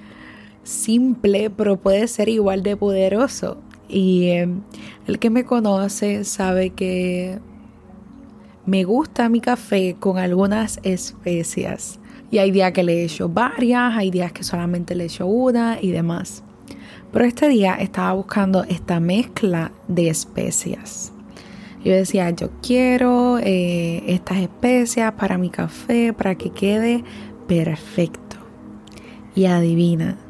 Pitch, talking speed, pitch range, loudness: 195 Hz, 125 wpm, 185-225 Hz, -19 LUFS